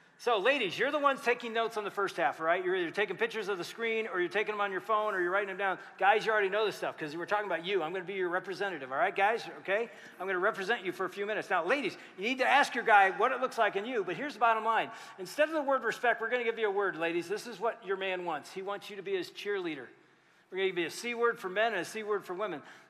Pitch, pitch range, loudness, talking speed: 210 Hz, 190-235 Hz, -31 LUFS, 320 wpm